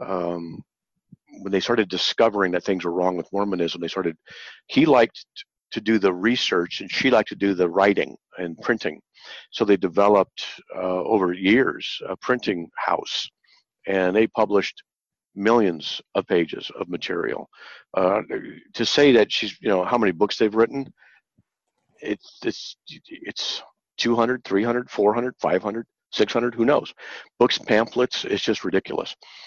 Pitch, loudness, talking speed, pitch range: 100 Hz, -22 LUFS, 150 wpm, 90-115 Hz